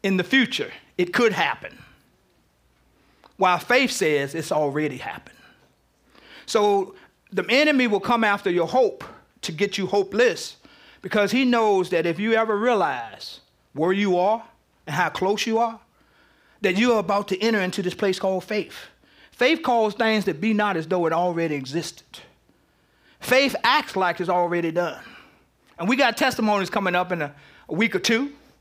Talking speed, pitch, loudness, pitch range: 170 wpm, 200 Hz, -22 LUFS, 175-230 Hz